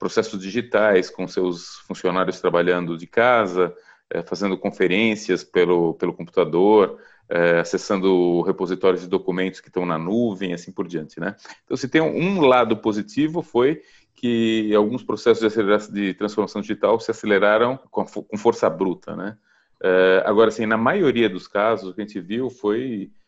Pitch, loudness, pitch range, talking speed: 100 Hz, -21 LUFS, 90-115 Hz, 145 wpm